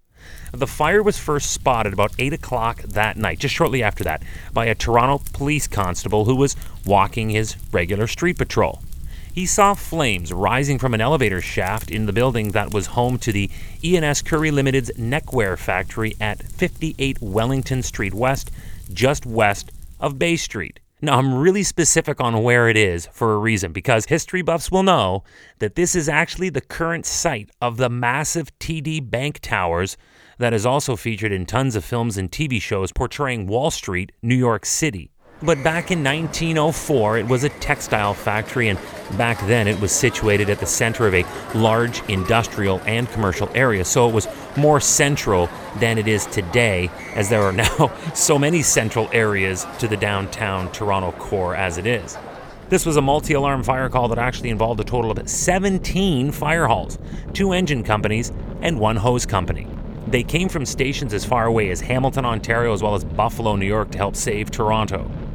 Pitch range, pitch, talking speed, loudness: 105-140 Hz, 115 Hz, 180 wpm, -20 LUFS